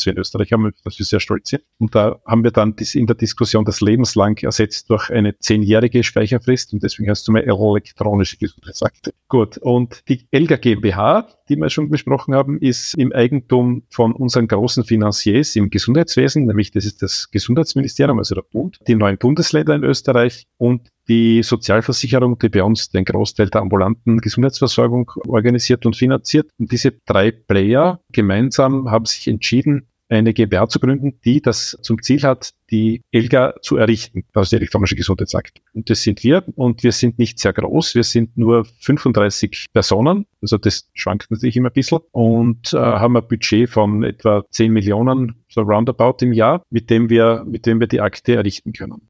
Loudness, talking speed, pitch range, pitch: -16 LUFS, 180 wpm, 105-125 Hz, 115 Hz